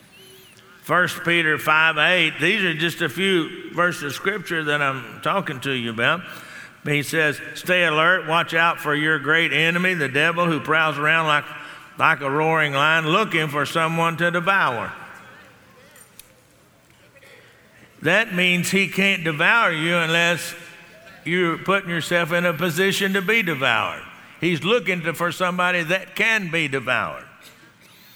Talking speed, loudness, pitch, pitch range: 145 wpm, -20 LUFS, 170 Hz, 155-180 Hz